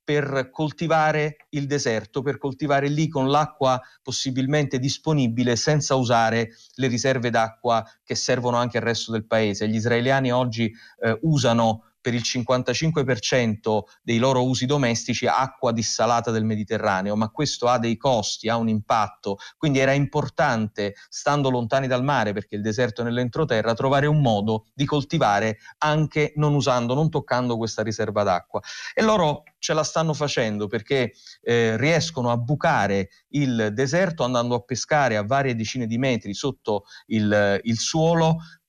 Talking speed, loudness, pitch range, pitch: 150 wpm, -23 LUFS, 115-145 Hz, 125 Hz